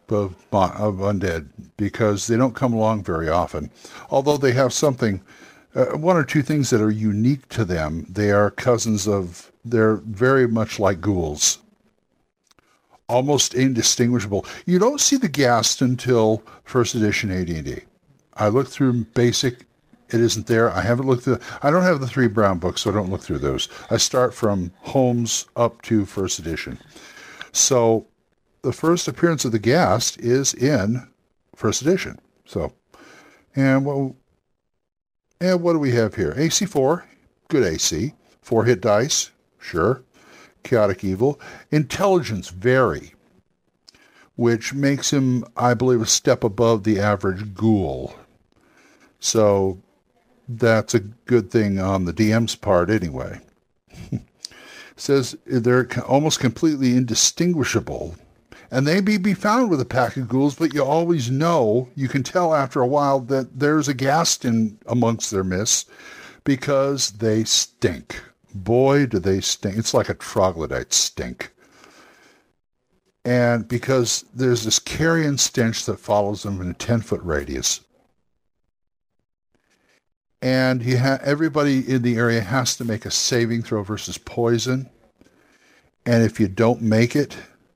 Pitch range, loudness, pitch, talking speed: 105-135 Hz, -20 LUFS, 120 Hz, 140 wpm